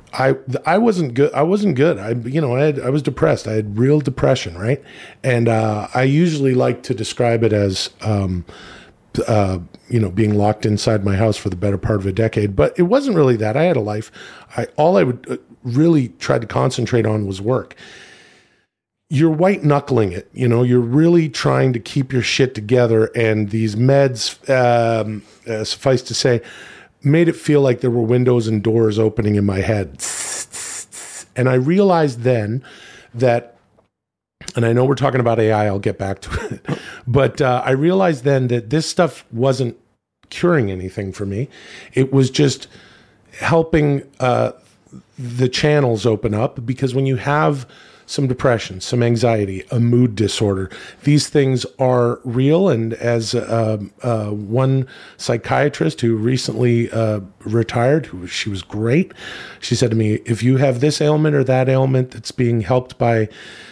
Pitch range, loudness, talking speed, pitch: 110-135 Hz, -17 LUFS, 175 wpm, 120 Hz